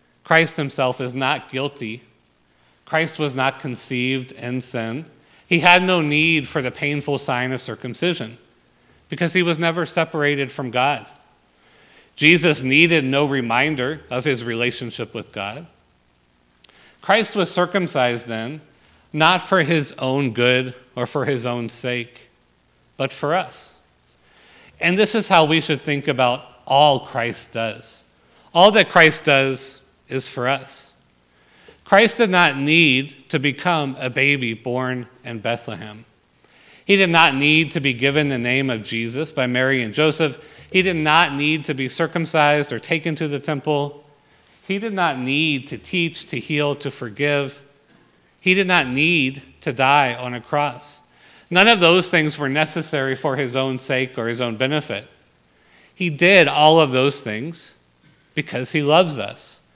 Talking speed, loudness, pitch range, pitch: 155 wpm, -18 LUFS, 125-160 Hz, 140 Hz